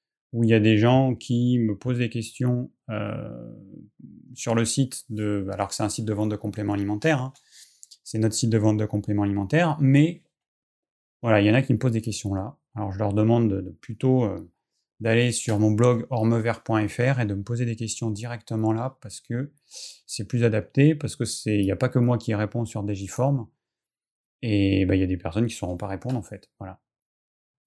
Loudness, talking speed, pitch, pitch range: -24 LUFS, 220 wpm, 115 Hz, 105-125 Hz